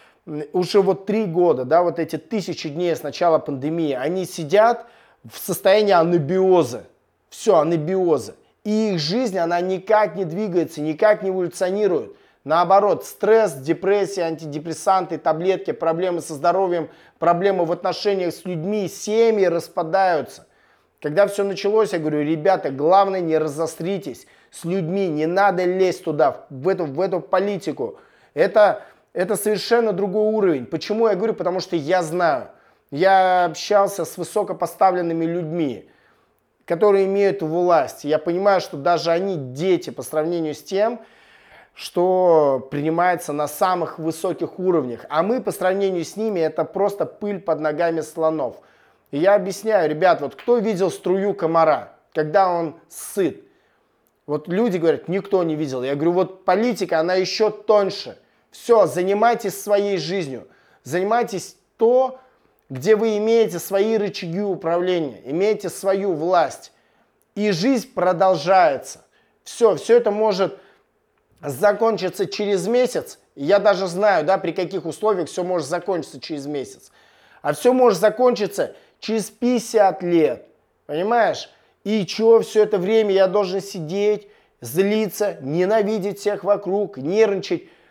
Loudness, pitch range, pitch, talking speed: -20 LUFS, 170-205 Hz, 185 Hz, 135 wpm